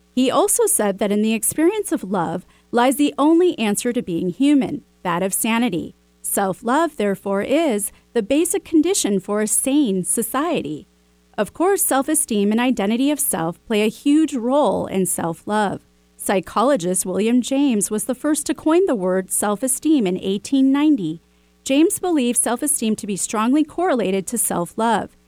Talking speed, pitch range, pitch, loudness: 165 wpm, 195-290 Hz, 230 Hz, -19 LUFS